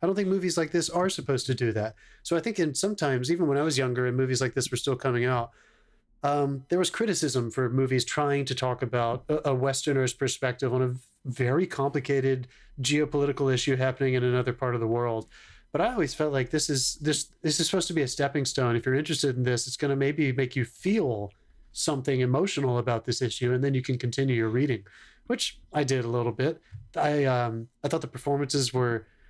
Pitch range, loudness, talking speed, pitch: 125-150 Hz, -27 LUFS, 225 wpm, 135 Hz